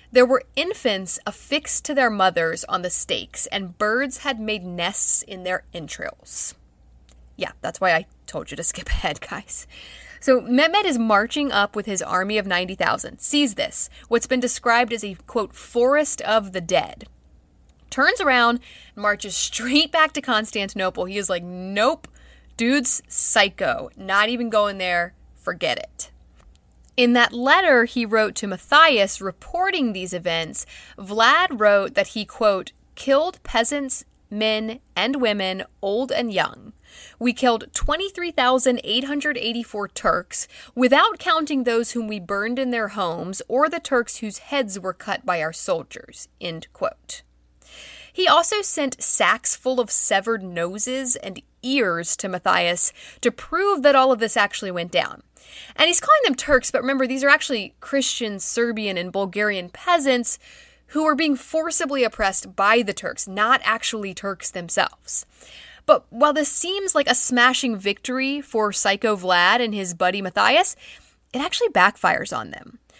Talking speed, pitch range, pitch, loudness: 150 wpm, 195-270 Hz, 230 Hz, -20 LUFS